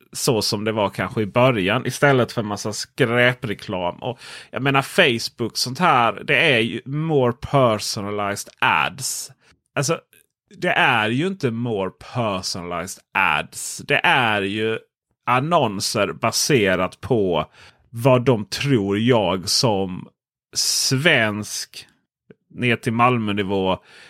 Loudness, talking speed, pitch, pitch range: -20 LUFS, 120 wpm, 115 Hz, 100-130 Hz